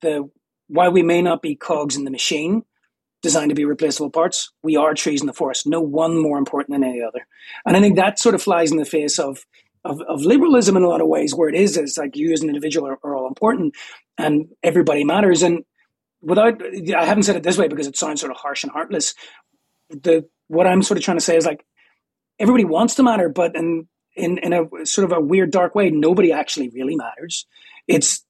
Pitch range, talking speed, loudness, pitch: 150-190 Hz, 230 wpm, -18 LUFS, 165 Hz